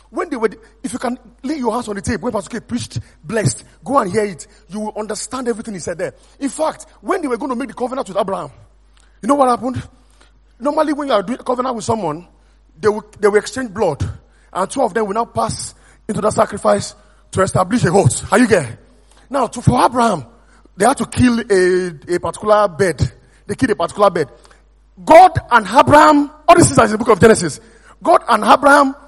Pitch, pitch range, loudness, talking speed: 225 Hz, 205-265 Hz, -16 LUFS, 220 wpm